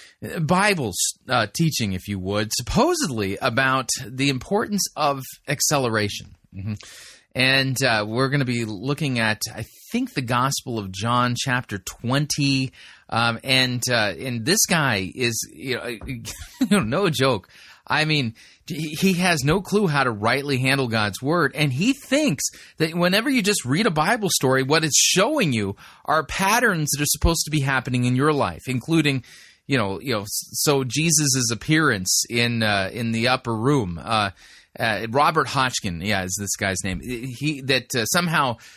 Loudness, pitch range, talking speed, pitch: -21 LUFS, 115-155 Hz, 165 wpm, 130 Hz